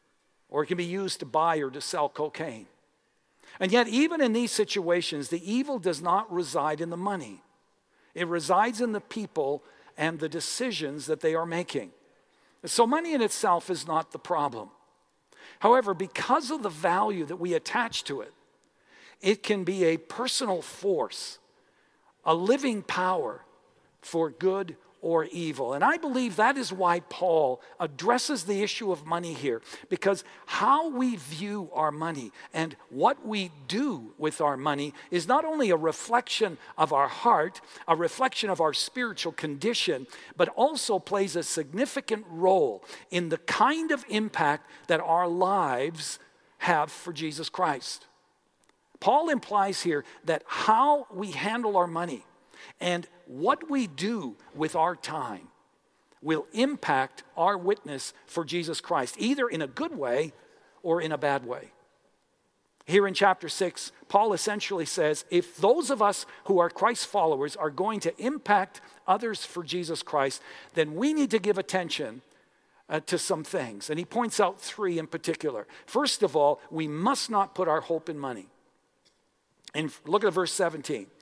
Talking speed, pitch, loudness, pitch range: 160 wpm, 185 Hz, -28 LUFS, 160-235 Hz